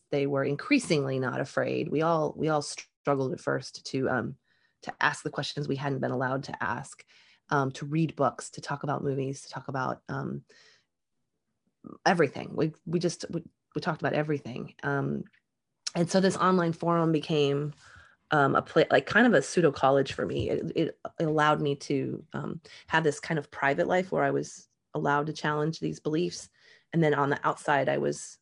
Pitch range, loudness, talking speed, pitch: 140-160 Hz, -28 LUFS, 190 wpm, 150 Hz